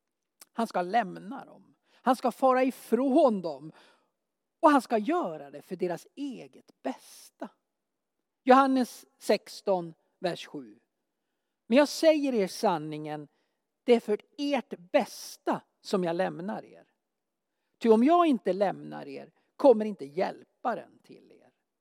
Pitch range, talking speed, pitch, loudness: 185-270 Hz, 130 wpm, 225 Hz, -28 LUFS